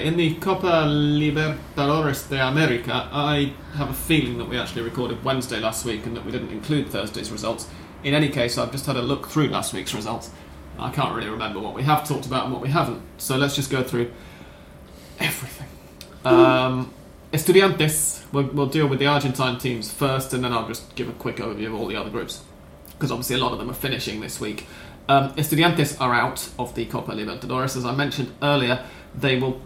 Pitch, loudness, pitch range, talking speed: 130 Hz, -23 LUFS, 115-145 Hz, 205 wpm